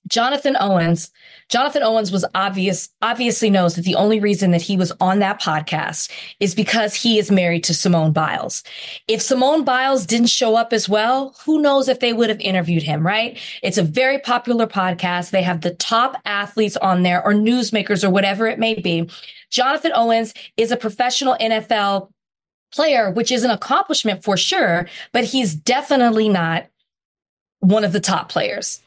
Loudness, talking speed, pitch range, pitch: -18 LUFS, 175 wpm, 185-240 Hz, 210 Hz